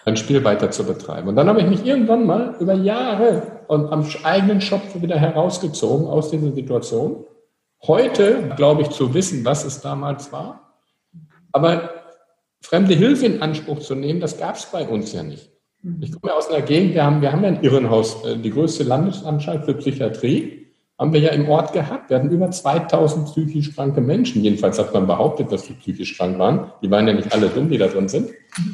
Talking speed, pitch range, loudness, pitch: 200 wpm, 140-185 Hz, -19 LUFS, 155 Hz